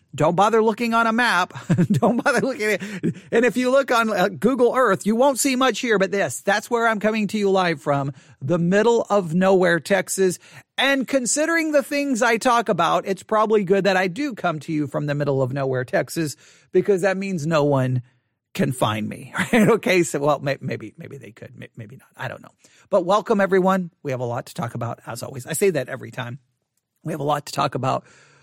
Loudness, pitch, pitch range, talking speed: -21 LUFS, 190 Hz, 145-225 Hz, 220 wpm